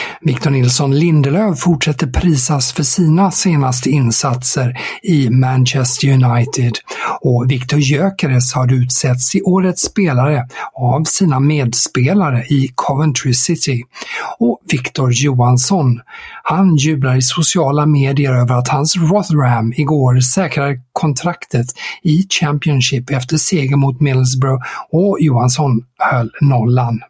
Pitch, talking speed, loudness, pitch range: 140 Hz, 115 wpm, -14 LUFS, 125-155 Hz